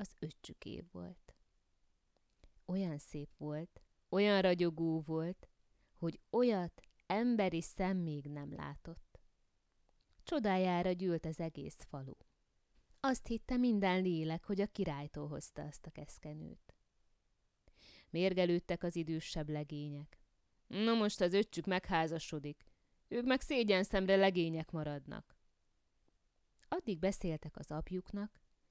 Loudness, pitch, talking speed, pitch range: -37 LUFS, 170 Hz, 110 wpm, 150-195 Hz